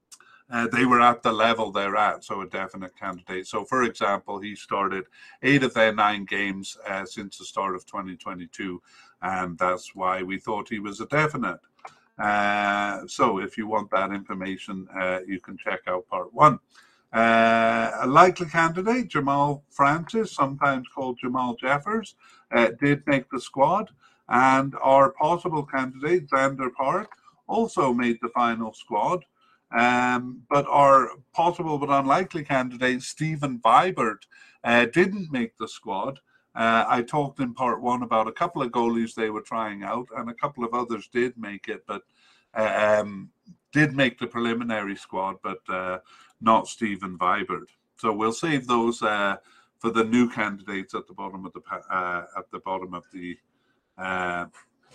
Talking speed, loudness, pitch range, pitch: 160 wpm, -24 LUFS, 100-140 Hz, 120 Hz